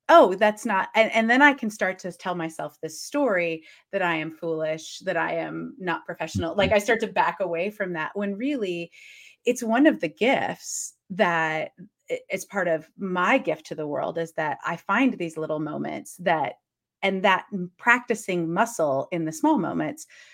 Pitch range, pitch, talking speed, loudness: 165-230 Hz, 190 Hz, 185 wpm, -25 LUFS